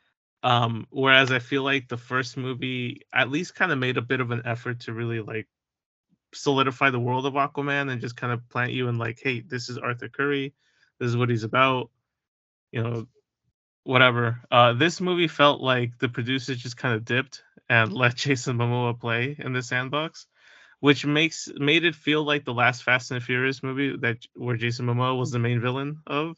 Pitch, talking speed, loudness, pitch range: 130 Hz, 200 wpm, -24 LUFS, 120-140 Hz